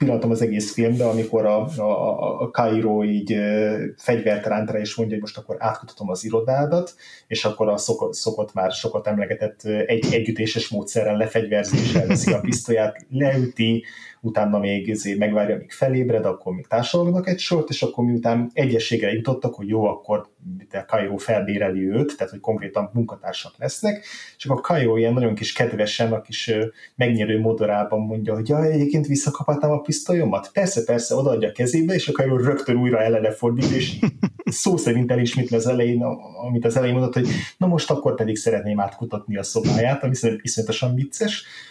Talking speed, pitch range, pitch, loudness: 170 wpm, 105-130 Hz, 115 Hz, -22 LUFS